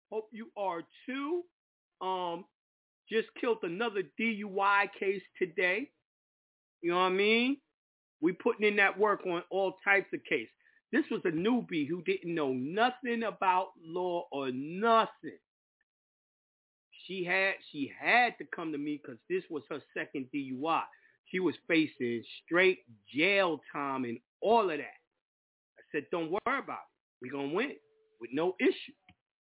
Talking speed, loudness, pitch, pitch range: 155 wpm, -32 LUFS, 200 Hz, 175-260 Hz